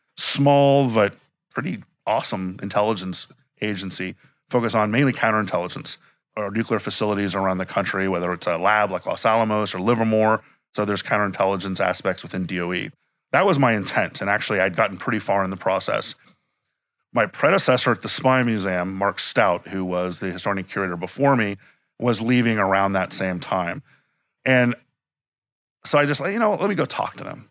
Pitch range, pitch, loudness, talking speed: 95-120 Hz, 105 Hz, -22 LUFS, 170 wpm